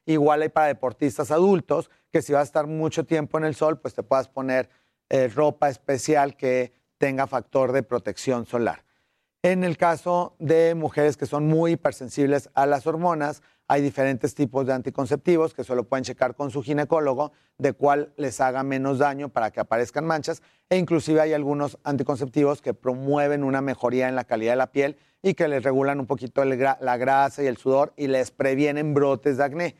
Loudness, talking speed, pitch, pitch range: -24 LUFS, 190 wpm, 145 Hz, 135-150 Hz